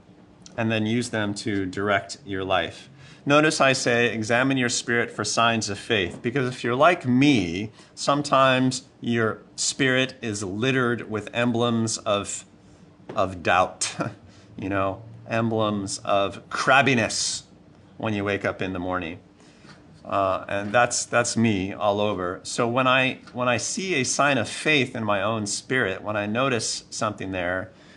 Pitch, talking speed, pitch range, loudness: 115 Hz, 150 wpm, 100-125 Hz, -23 LUFS